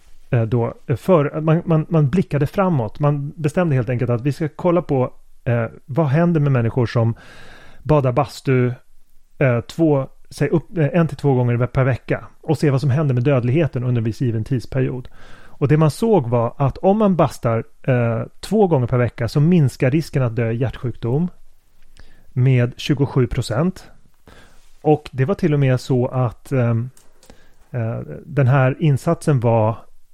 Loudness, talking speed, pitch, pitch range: -19 LUFS, 165 wpm, 135 Hz, 120-155 Hz